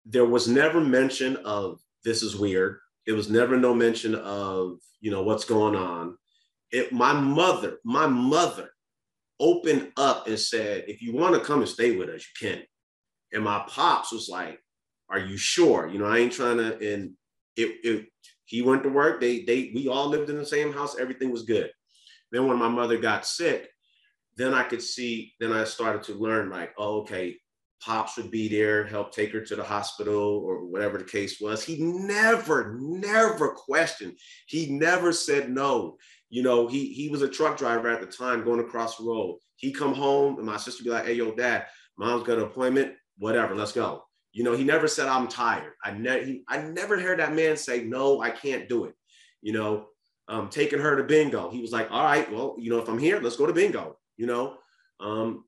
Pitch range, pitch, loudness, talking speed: 110-145 Hz, 120 Hz, -26 LUFS, 210 wpm